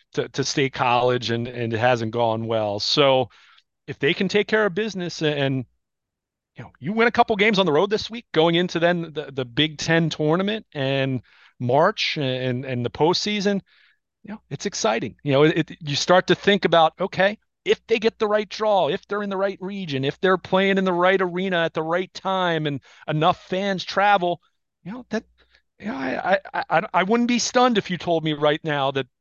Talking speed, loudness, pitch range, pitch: 220 wpm, -22 LUFS, 140-200 Hz, 175 Hz